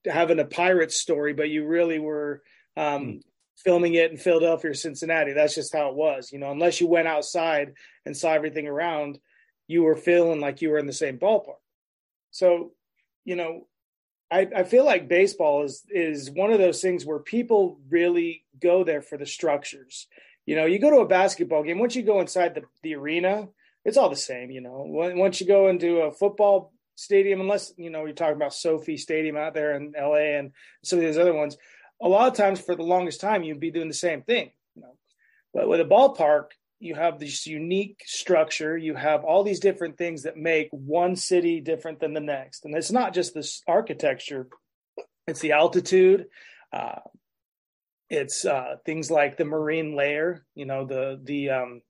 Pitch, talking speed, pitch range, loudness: 165 Hz, 195 wpm, 150-180 Hz, -24 LUFS